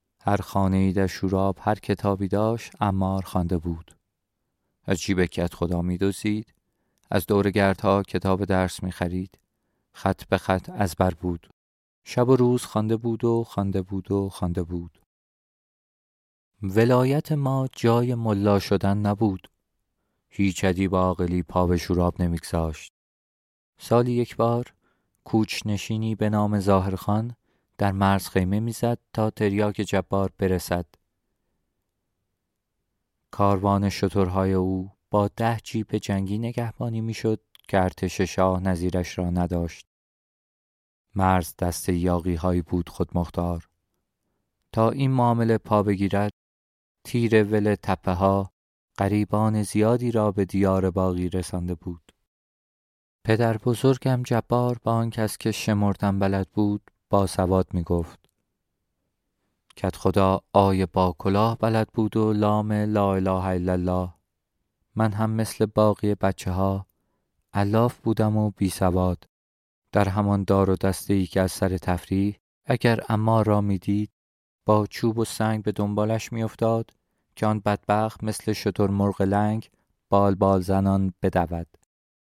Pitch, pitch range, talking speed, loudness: 100 Hz, 90-110 Hz, 130 wpm, -24 LUFS